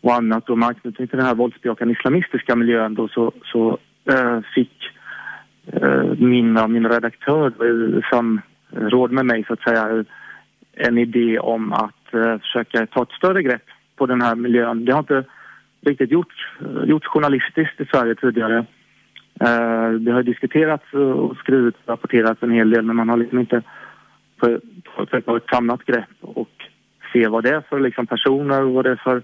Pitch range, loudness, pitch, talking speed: 115-130 Hz, -19 LUFS, 120 Hz, 180 wpm